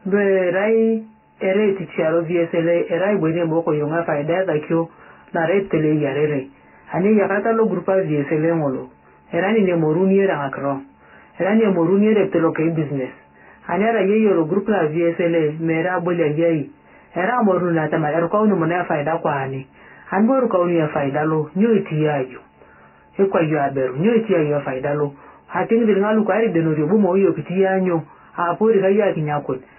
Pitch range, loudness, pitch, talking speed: 155-195 Hz, -19 LUFS, 170 Hz, 170 wpm